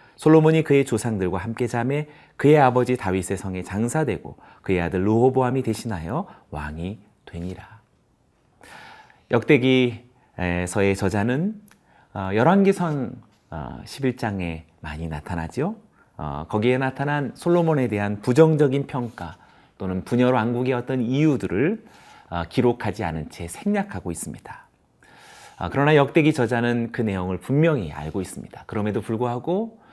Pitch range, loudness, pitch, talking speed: 95-140 Hz, -22 LUFS, 120 Hz, 285 characters per minute